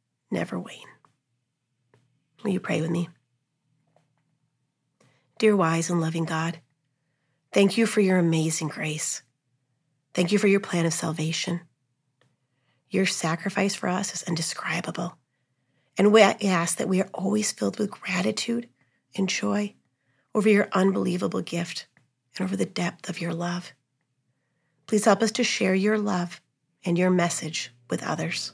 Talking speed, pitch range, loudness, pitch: 140 wpm, 135-190 Hz, -25 LUFS, 165 Hz